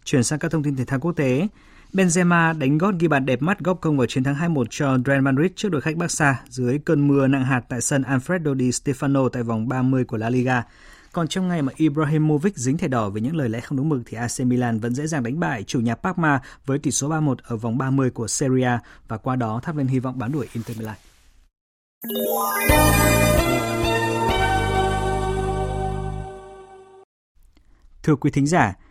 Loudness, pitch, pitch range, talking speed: -21 LUFS, 130 Hz, 120-155 Hz, 200 wpm